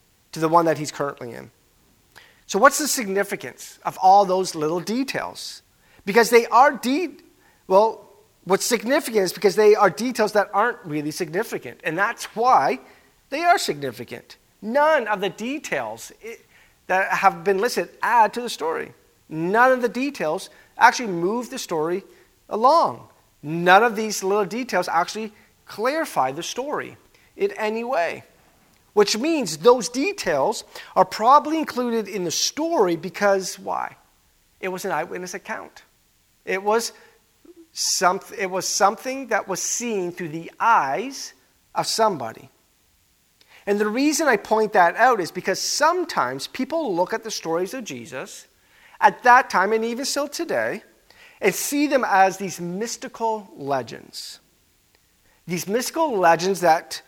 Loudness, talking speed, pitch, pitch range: -21 LUFS, 145 wpm, 210 Hz, 185-260 Hz